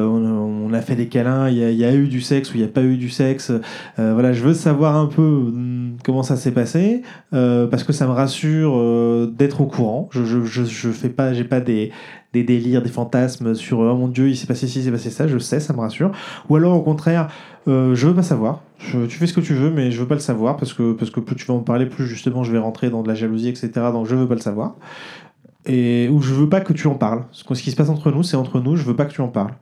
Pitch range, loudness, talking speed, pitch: 120-145 Hz, -19 LUFS, 300 wpm, 130 Hz